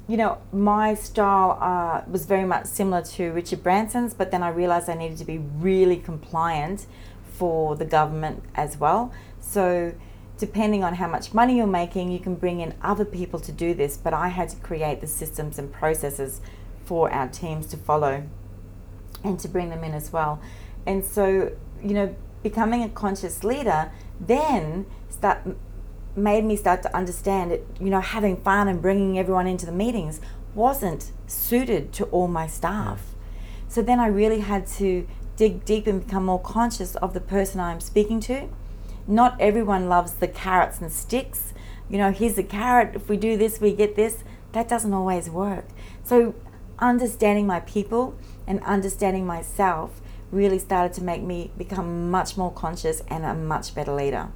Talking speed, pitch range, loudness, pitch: 175 wpm, 160-205 Hz, -24 LUFS, 185 Hz